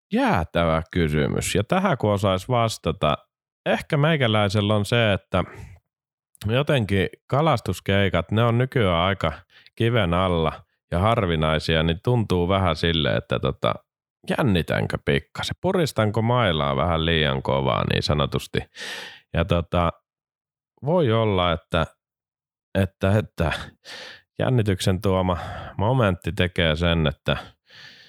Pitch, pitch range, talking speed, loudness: 95 Hz, 85-115 Hz, 105 wpm, -23 LUFS